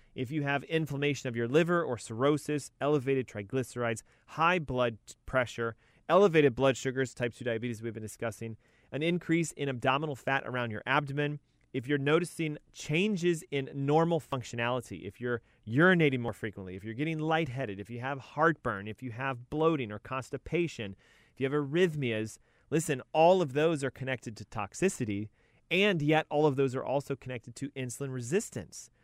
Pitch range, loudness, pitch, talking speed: 120-155 Hz, -31 LUFS, 135 Hz, 165 wpm